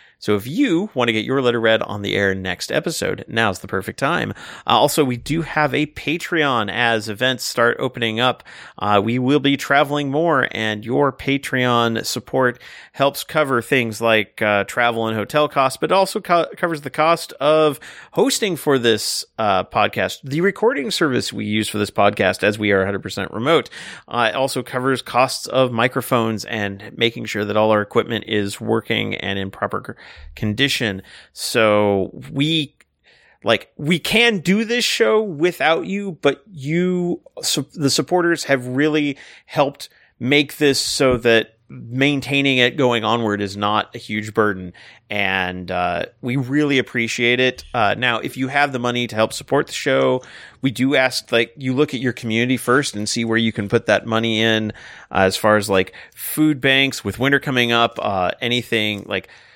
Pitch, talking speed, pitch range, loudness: 125 Hz, 175 wpm, 110-140 Hz, -19 LUFS